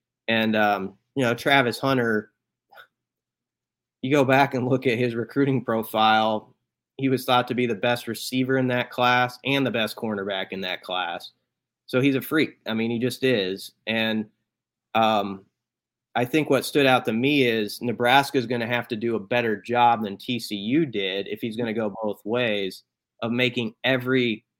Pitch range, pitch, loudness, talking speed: 110-130 Hz, 120 Hz, -23 LUFS, 185 wpm